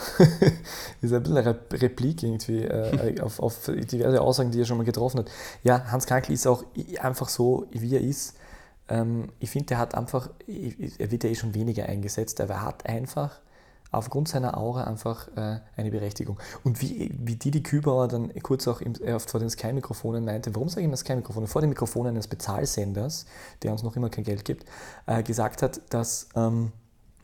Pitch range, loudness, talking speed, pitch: 115-130 Hz, -28 LUFS, 195 wpm, 120 Hz